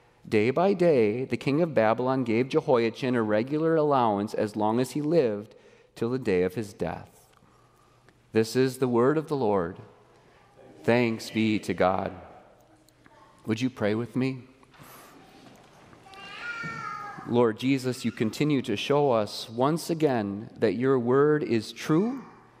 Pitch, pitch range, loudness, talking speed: 125 Hz, 110-145 Hz, -26 LUFS, 140 wpm